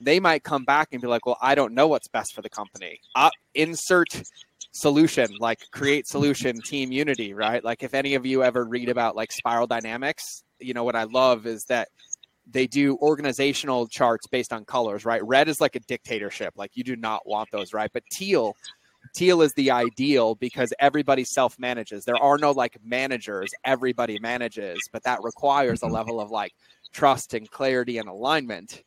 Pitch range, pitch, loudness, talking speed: 115-140 Hz, 125 Hz, -24 LUFS, 190 wpm